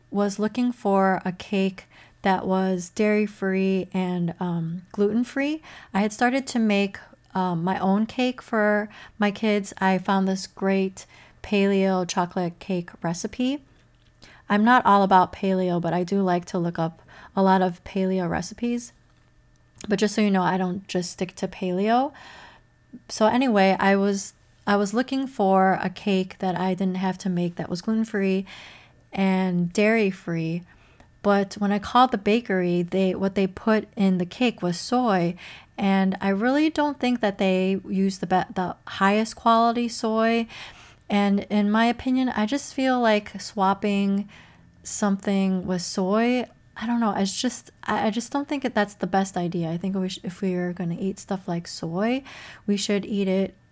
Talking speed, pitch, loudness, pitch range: 175 wpm, 195 Hz, -24 LUFS, 185-220 Hz